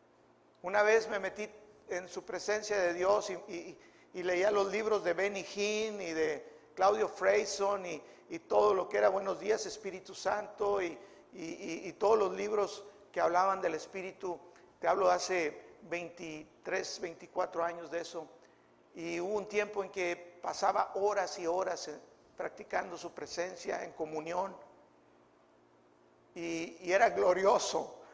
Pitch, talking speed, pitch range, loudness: 185 Hz, 150 wpm, 170-205 Hz, -34 LUFS